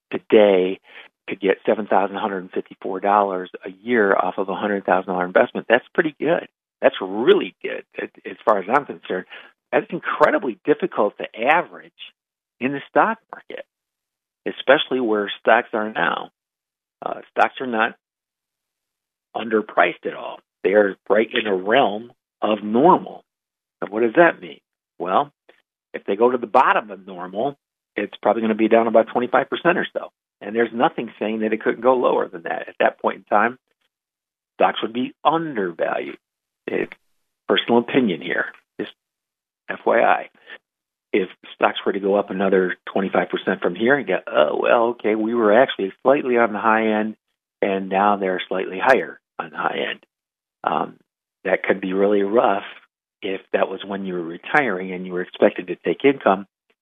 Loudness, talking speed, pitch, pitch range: -20 LUFS, 170 wpm, 110 Hz, 95-125 Hz